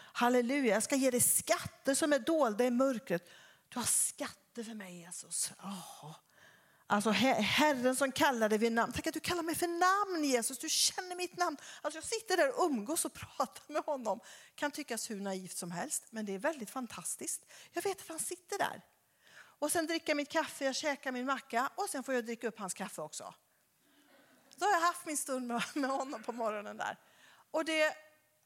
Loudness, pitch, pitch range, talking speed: -34 LUFS, 270 Hz, 230-320 Hz, 205 wpm